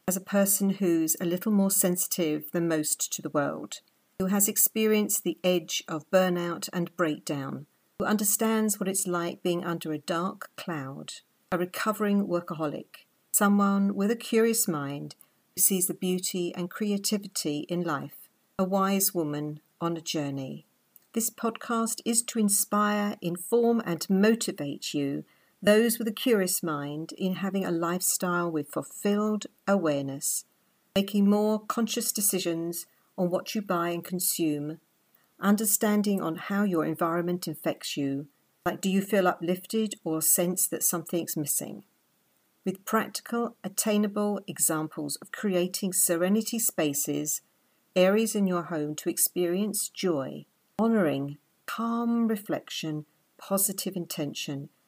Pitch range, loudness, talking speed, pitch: 165-205 Hz, -27 LUFS, 135 wpm, 185 Hz